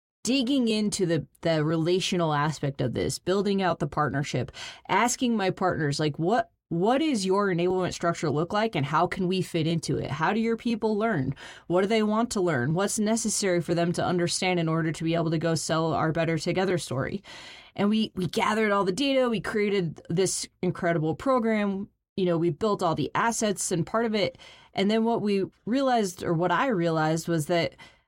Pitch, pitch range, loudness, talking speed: 180 Hz, 165-215 Hz, -26 LUFS, 200 wpm